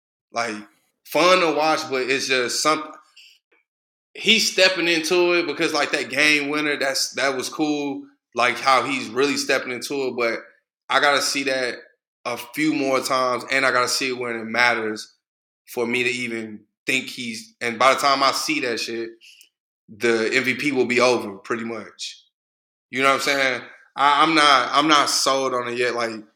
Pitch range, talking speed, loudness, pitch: 120-150 Hz, 185 wpm, -20 LUFS, 130 Hz